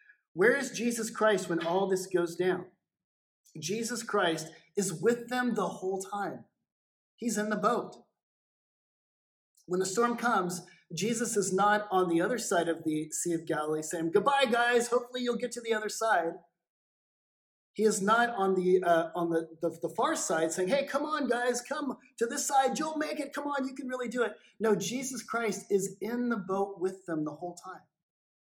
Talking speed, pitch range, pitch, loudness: 190 wpm, 180-240 Hz, 210 Hz, -30 LUFS